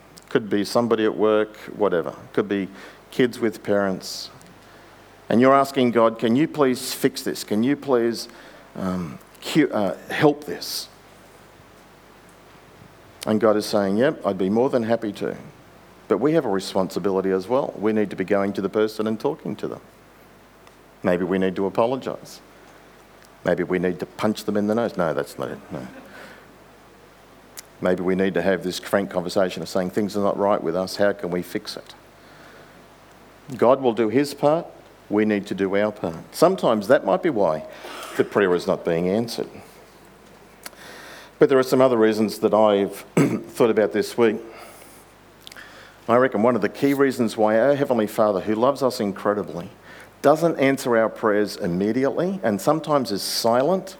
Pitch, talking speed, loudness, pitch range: 105 Hz, 170 wpm, -22 LUFS, 95-120 Hz